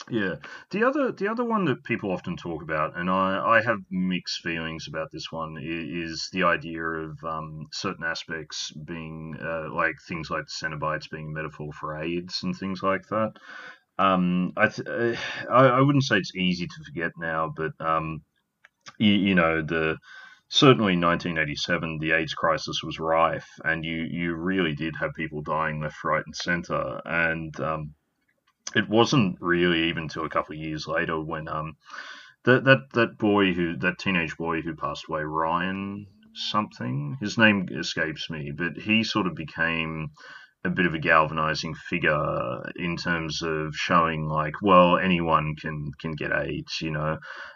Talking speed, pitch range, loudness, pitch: 170 wpm, 80-95 Hz, -25 LUFS, 80 Hz